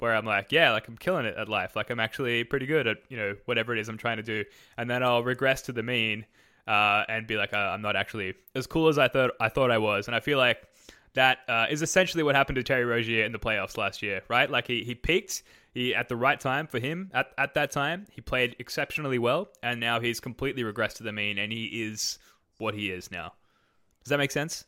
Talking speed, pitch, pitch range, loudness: 260 wpm, 120 Hz, 110-130 Hz, -27 LUFS